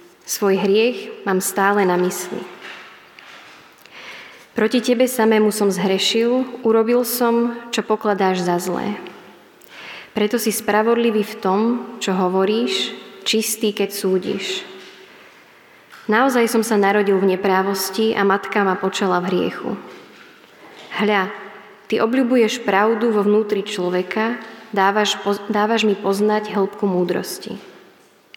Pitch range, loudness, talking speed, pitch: 195-225 Hz, -19 LUFS, 110 wpm, 210 Hz